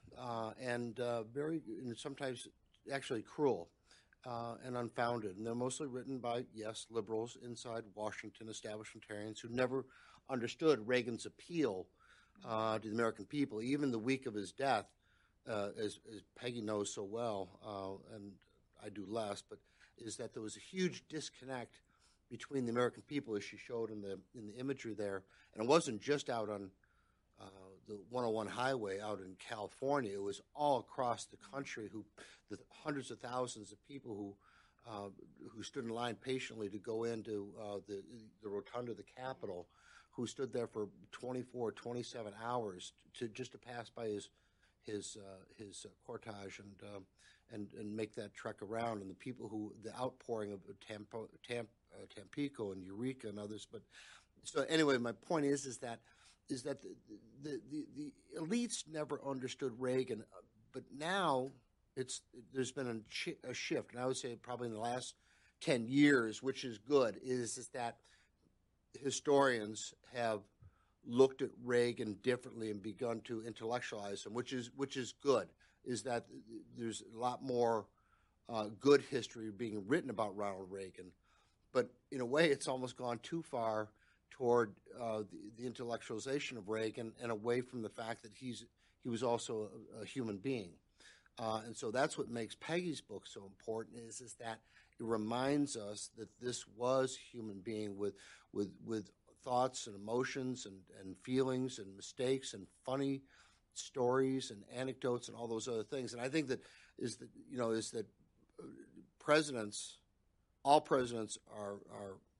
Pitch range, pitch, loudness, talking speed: 105-130 Hz, 115 Hz, -41 LUFS, 165 wpm